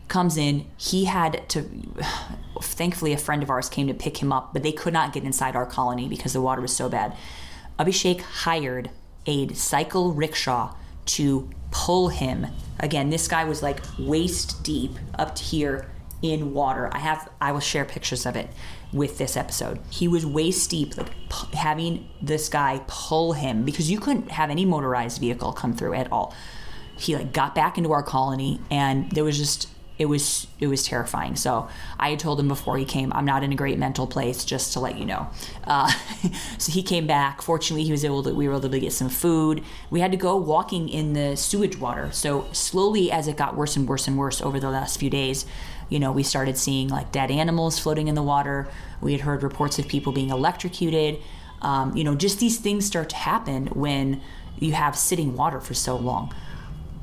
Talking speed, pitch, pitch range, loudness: 205 wpm, 145 Hz, 135-165 Hz, -25 LUFS